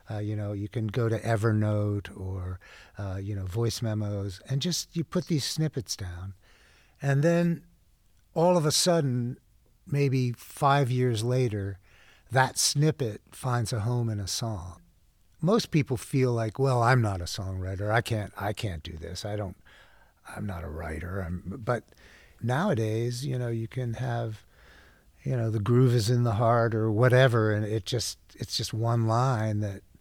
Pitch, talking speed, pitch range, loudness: 115 Hz, 170 wpm, 100-125 Hz, -28 LUFS